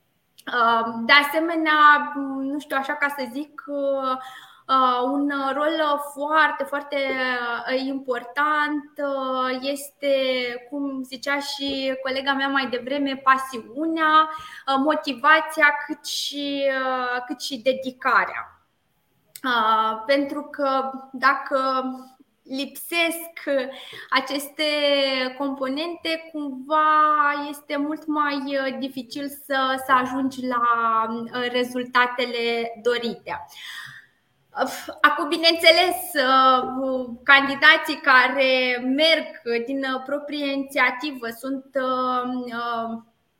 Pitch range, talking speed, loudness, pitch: 255-290 Hz, 75 wpm, -22 LUFS, 275 Hz